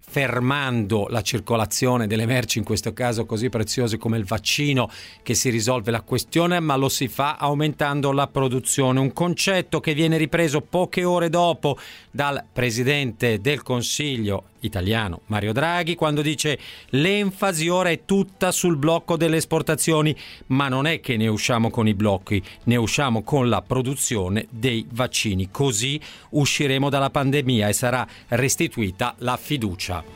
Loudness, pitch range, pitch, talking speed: -22 LUFS, 115-150 Hz, 130 Hz, 150 wpm